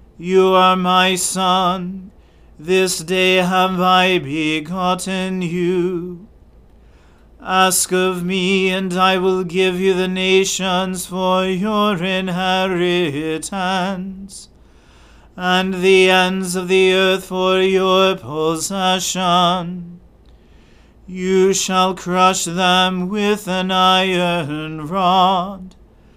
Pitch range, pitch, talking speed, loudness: 180-190 Hz, 185 Hz, 90 wpm, -16 LUFS